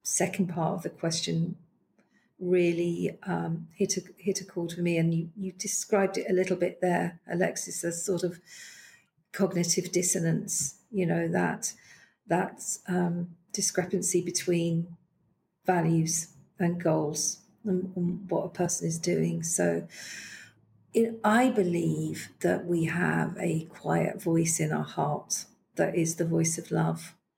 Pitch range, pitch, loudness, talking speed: 165-185 Hz, 175 Hz, -29 LUFS, 140 wpm